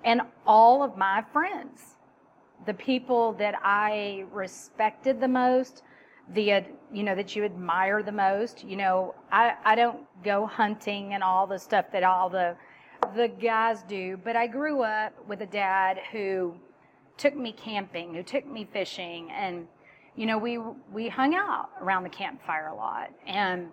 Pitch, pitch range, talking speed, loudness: 210 Hz, 190-235 Hz, 165 wpm, -27 LUFS